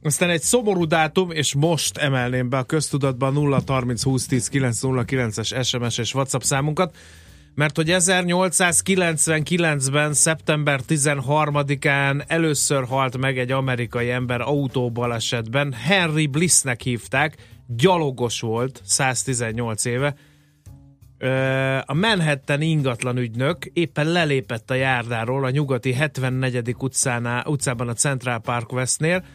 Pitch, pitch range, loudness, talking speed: 135 Hz, 125-150 Hz, -21 LUFS, 100 wpm